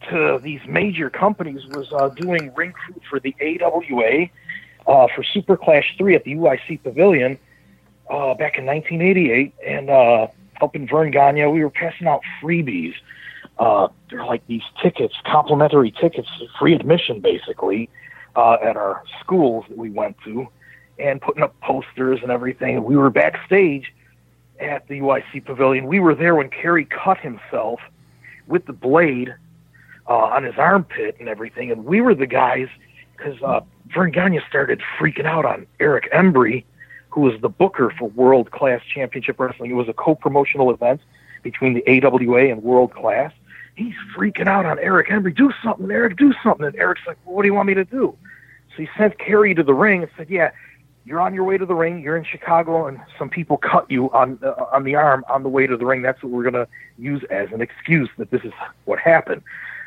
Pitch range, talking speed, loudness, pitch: 130-170 Hz, 195 wpm, -18 LUFS, 145 Hz